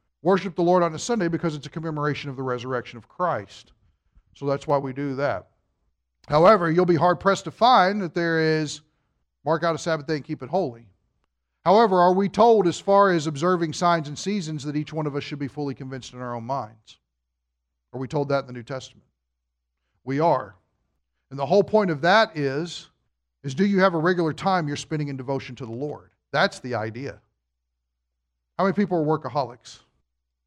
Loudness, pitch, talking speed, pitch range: -23 LUFS, 145 Hz, 205 wpm, 110-170 Hz